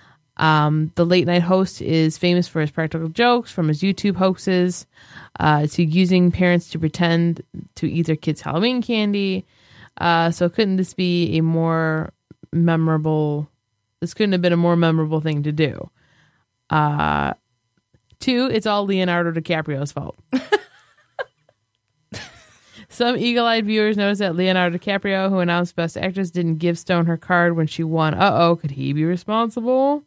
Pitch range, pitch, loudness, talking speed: 160-190 Hz, 170 Hz, -20 LUFS, 155 wpm